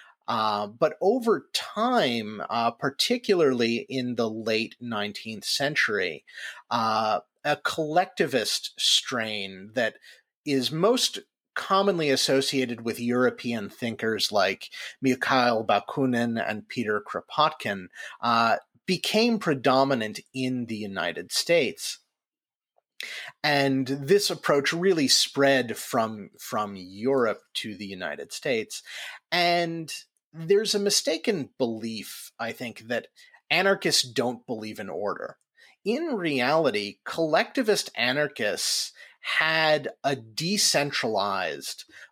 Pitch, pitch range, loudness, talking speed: 130 Hz, 110-175 Hz, -26 LUFS, 95 wpm